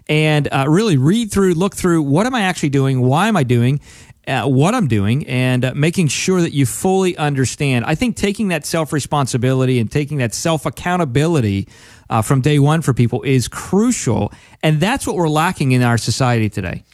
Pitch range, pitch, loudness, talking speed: 125-170 Hz, 145 Hz, -16 LUFS, 190 wpm